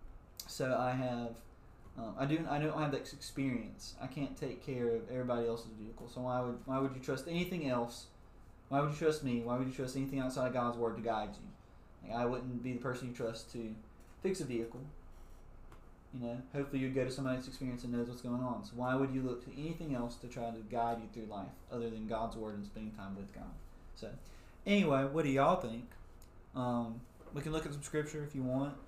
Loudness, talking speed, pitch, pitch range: -38 LUFS, 230 wpm, 125 Hz, 115-135 Hz